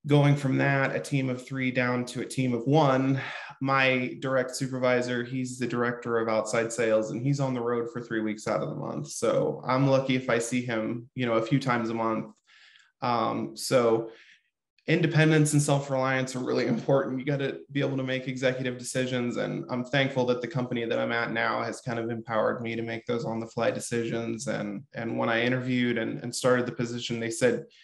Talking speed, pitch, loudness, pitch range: 215 wpm, 125 Hz, -27 LUFS, 115-130 Hz